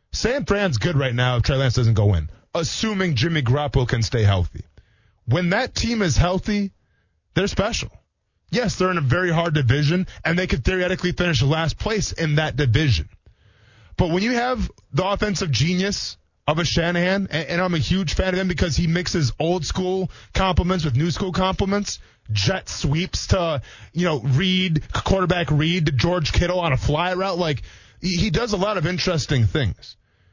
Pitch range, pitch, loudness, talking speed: 125-185 Hz, 160 Hz, -21 LUFS, 180 wpm